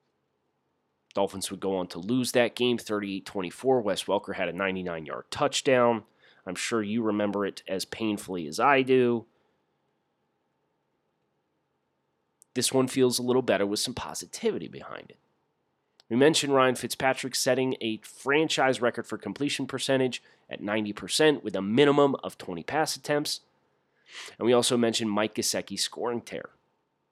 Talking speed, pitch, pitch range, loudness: 145 wpm, 120 Hz, 105-130 Hz, -27 LUFS